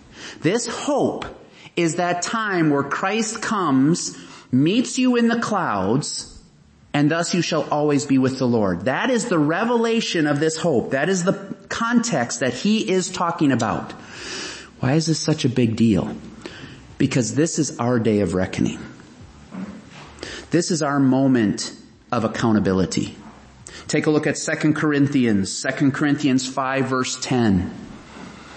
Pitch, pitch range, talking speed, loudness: 150 Hz, 130-180 Hz, 145 wpm, -21 LUFS